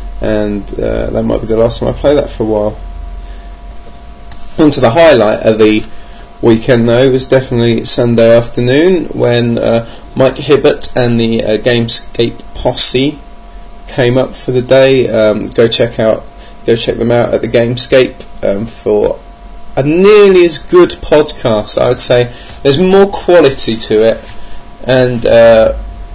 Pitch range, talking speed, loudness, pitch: 110-130 Hz, 160 wpm, -9 LUFS, 115 Hz